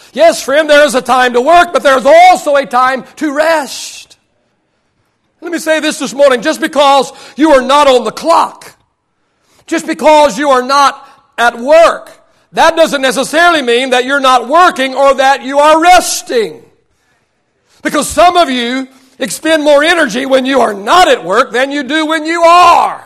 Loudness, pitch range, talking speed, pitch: -8 LUFS, 265-320 Hz, 180 wpm, 285 Hz